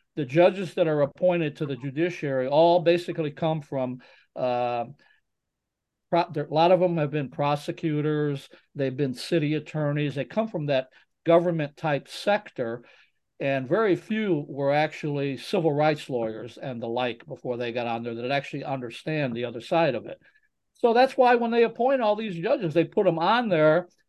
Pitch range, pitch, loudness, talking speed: 135-175 Hz, 150 Hz, -25 LUFS, 175 wpm